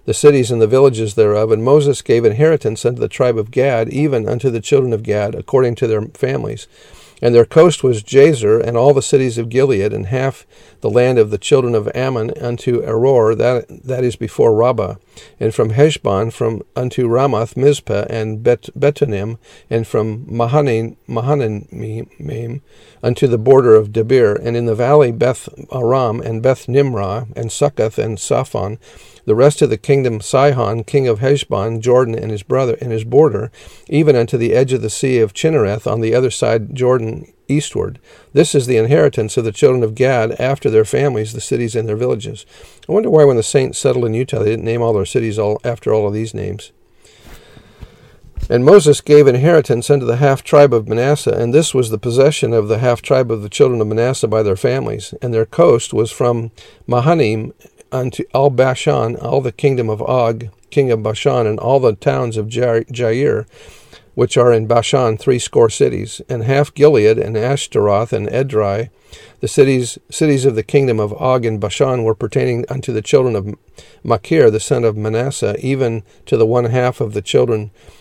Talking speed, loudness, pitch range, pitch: 190 wpm, -15 LUFS, 110-140 Hz, 120 Hz